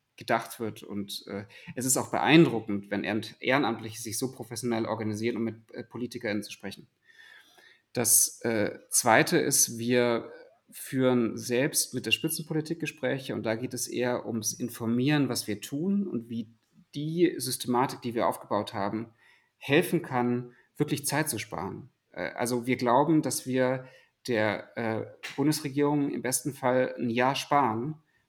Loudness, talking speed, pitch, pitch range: -28 LUFS, 150 wpm, 125 Hz, 115-145 Hz